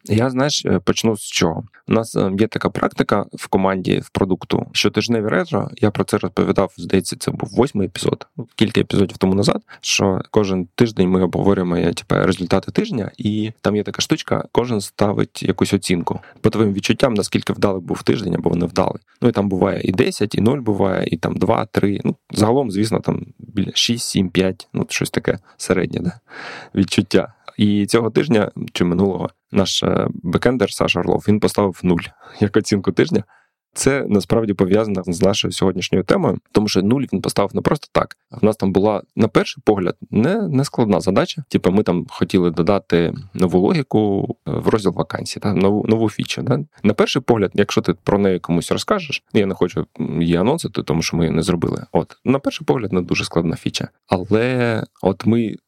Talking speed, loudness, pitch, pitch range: 185 wpm, -19 LUFS, 100 Hz, 95-110 Hz